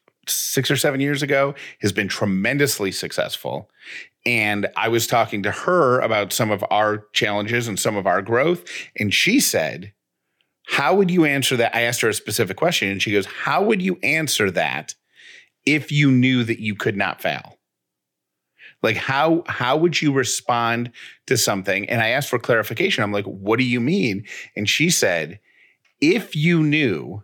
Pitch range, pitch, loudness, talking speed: 105-150 Hz, 125 Hz, -20 LUFS, 175 wpm